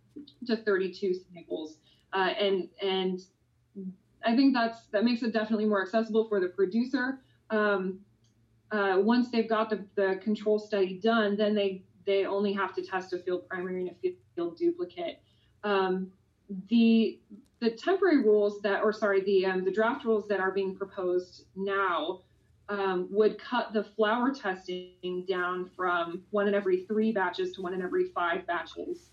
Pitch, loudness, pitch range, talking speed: 200 Hz, -29 LUFS, 185-220 Hz, 165 wpm